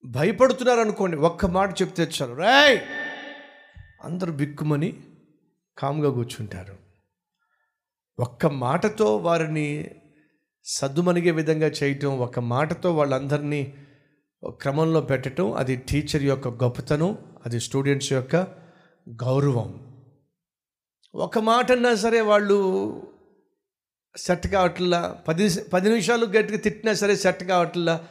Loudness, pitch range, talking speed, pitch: -23 LUFS, 140-195 Hz, 95 wpm, 165 Hz